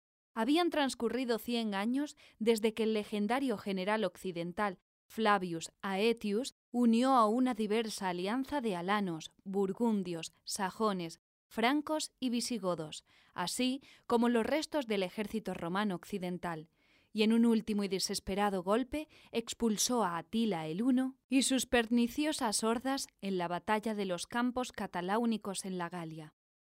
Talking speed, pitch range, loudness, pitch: 130 wpm, 190-240 Hz, -34 LUFS, 220 Hz